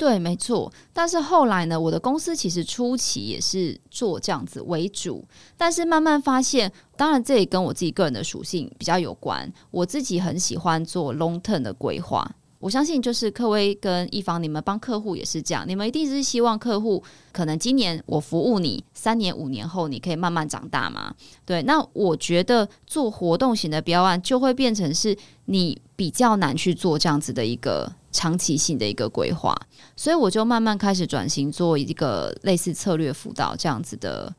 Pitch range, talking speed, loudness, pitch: 165-235 Hz, 305 characters per minute, -23 LUFS, 185 Hz